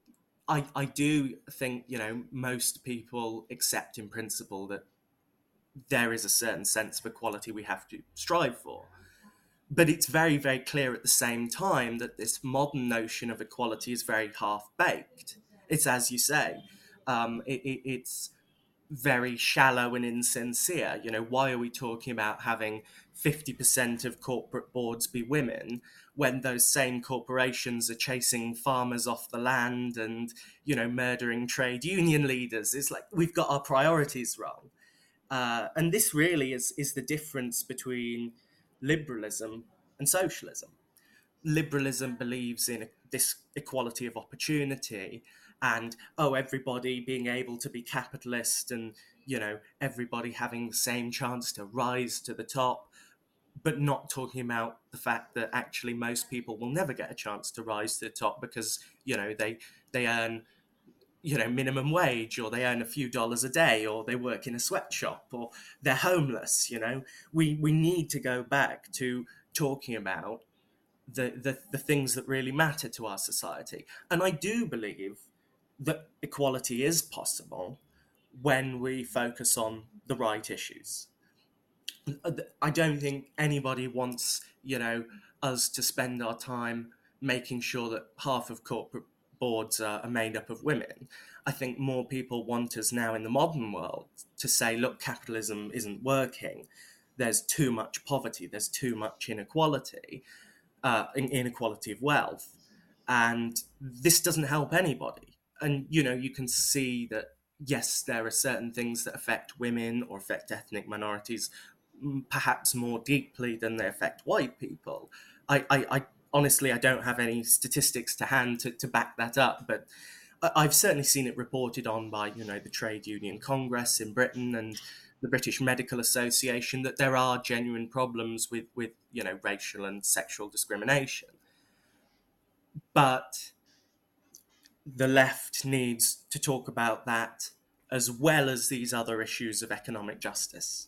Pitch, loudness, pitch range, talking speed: 125 Hz, -30 LUFS, 115-135 Hz, 160 wpm